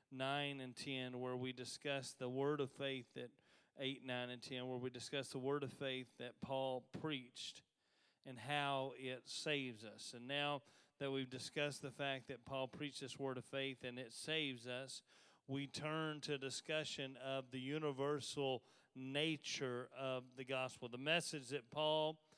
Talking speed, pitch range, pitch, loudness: 170 wpm, 130-145 Hz, 135 Hz, -45 LUFS